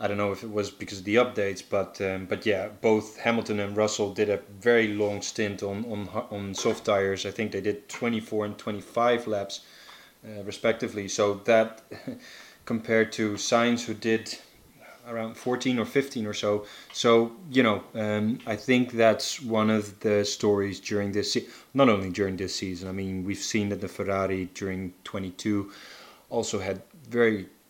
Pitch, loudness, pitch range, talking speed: 105 Hz, -27 LUFS, 100-115 Hz, 180 wpm